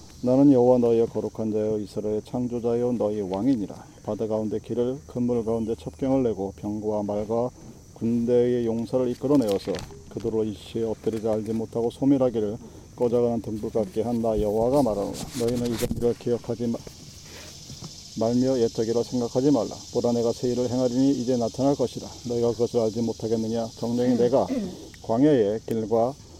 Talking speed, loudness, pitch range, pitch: 375 characters per minute, -25 LUFS, 110-120 Hz, 115 Hz